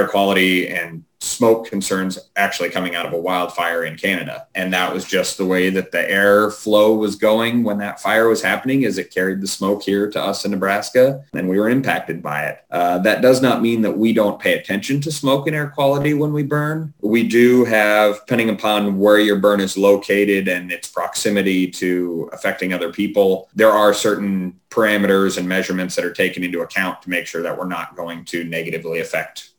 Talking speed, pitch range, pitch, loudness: 205 wpm, 95-110 Hz, 100 Hz, -18 LUFS